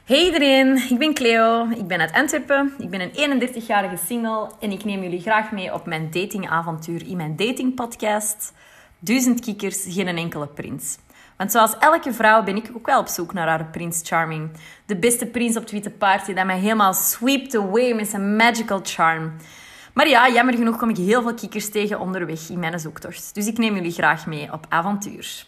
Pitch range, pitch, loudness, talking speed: 180-235 Hz, 210 Hz, -20 LUFS, 195 wpm